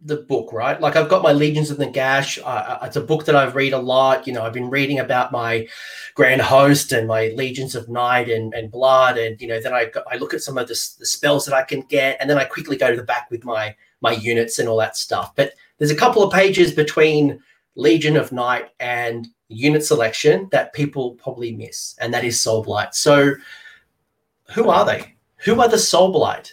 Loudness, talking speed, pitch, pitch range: -18 LUFS, 230 wpm, 135 Hz, 115-150 Hz